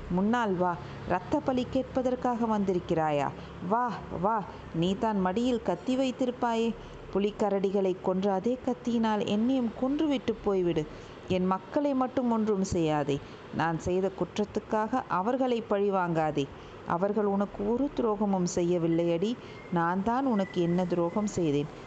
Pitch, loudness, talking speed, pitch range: 205 Hz, -29 LUFS, 115 wpm, 180-240 Hz